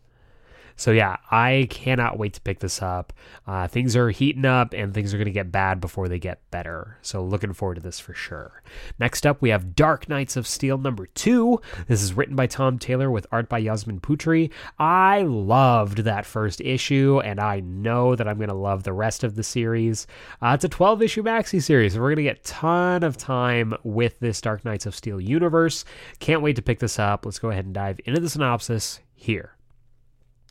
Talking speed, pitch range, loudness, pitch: 215 wpm, 105-135 Hz, -23 LUFS, 120 Hz